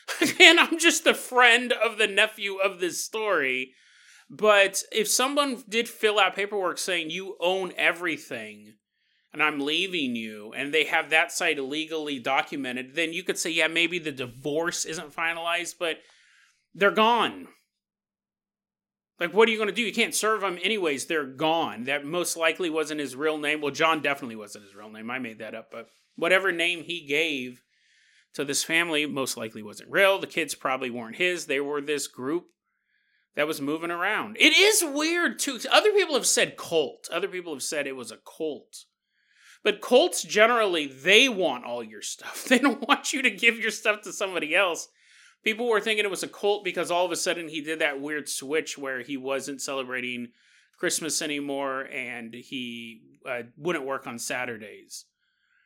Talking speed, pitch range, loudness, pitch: 180 wpm, 140-215 Hz, -24 LUFS, 170 Hz